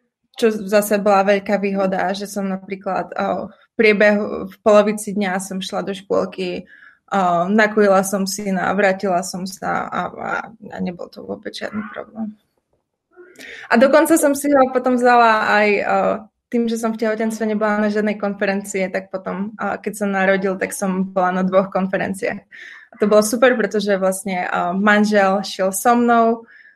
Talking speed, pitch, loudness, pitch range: 160 wpm, 205 Hz, -18 LUFS, 195-225 Hz